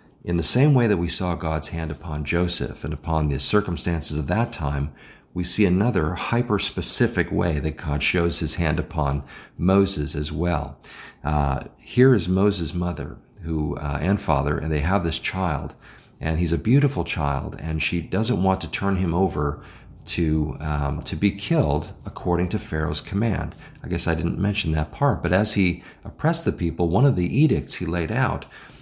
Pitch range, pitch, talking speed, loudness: 75-100 Hz, 85 Hz, 185 wpm, -23 LUFS